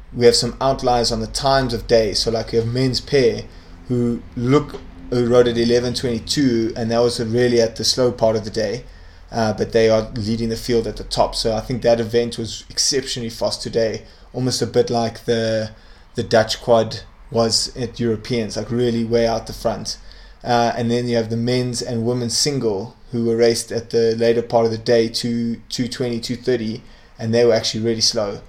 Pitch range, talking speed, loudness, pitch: 110-120 Hz, 205 wpm, -19 LUFS, 115 Hz